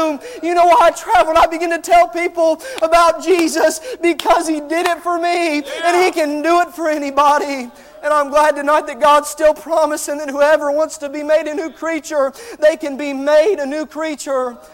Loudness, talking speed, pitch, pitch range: -15 LUFS, 205 wpm, 310 Hz, 295-335 Hz